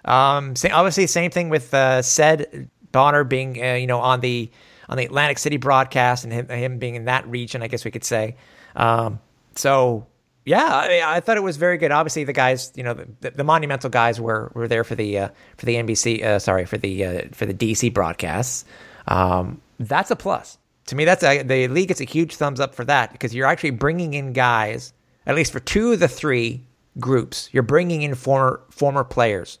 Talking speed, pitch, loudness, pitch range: 220 wpm, 130 Hz, -20 LUFS, 115-145 Hz